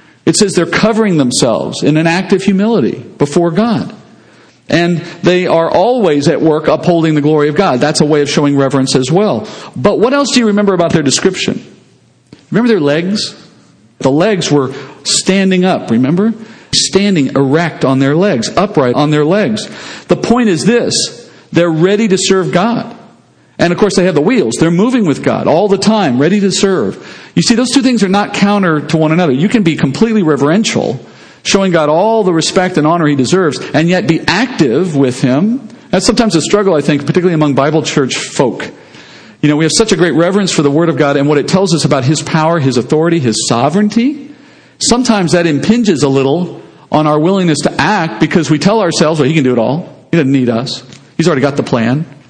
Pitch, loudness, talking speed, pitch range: 170 Hz, -11 LUFS, 205 wpm, 150-205 Hz